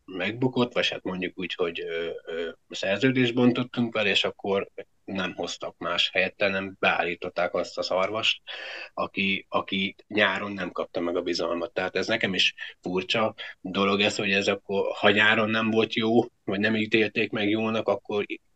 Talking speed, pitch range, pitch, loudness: 160 wpm, 100-125 Hz, 110 Hz, -26 LUFS